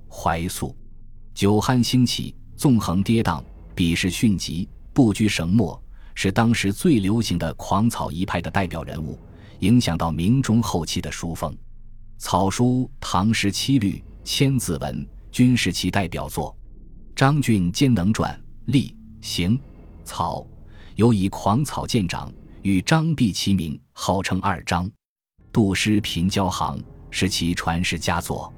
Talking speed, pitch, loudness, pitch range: 195 characters per minute, 100 Hz, -22 LUFS, 85-110 Hz